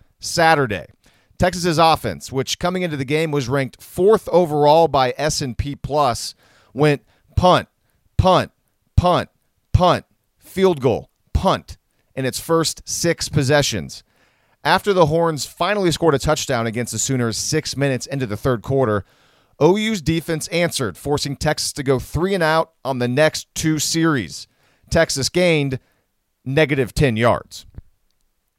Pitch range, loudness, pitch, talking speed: 125-165 Hz, -19 LUFS, 145 Hz, 135 wpm